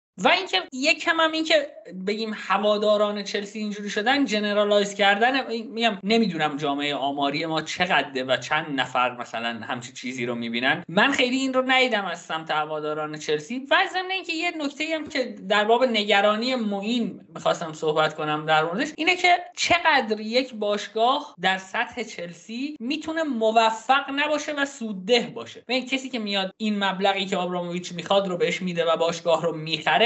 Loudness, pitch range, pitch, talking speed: -23 LUFS, 170-260 Hz, 210 Hz, 170 wpm